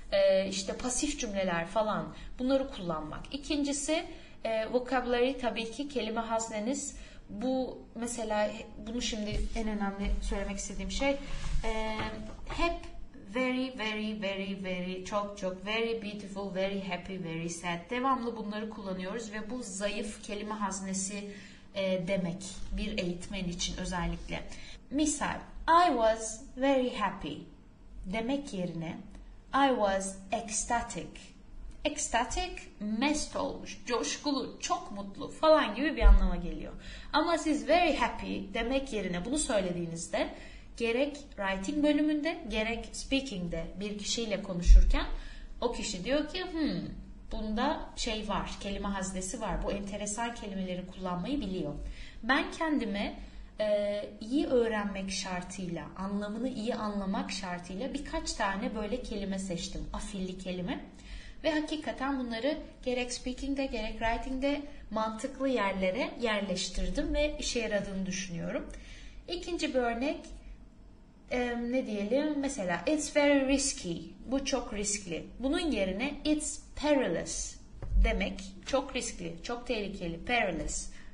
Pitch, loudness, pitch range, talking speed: 220 Hz, -33 LUFS, 195-270 Hz, 115 wpm